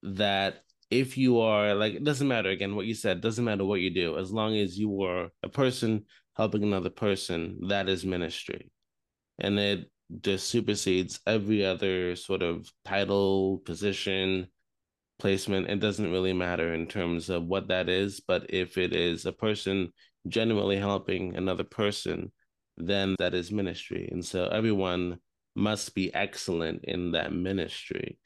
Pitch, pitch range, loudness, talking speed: 95 Hz, 90-105 Hz, -29 LUFS, 155 wpm